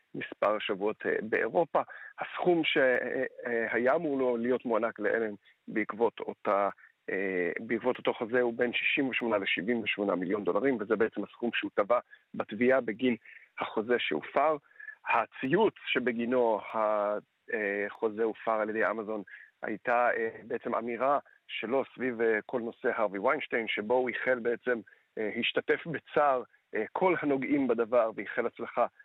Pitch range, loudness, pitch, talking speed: 110-130 Hz, -30 LUFS, 120 Hz, 120 wpm